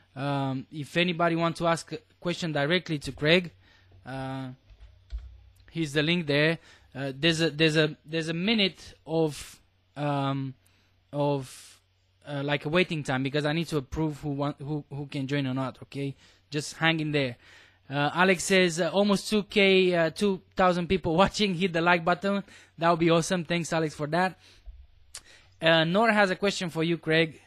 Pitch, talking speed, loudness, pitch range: 155 Hz, 175 wpm, -26 LUFS, 135-170 Hz